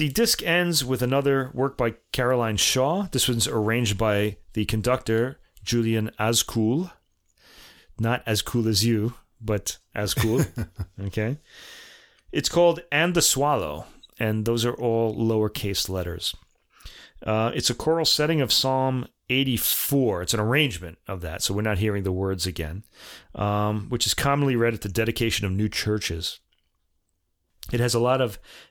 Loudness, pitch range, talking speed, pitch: -24 LUFS, 105-130 Hz, 155 wpm, 115 Hz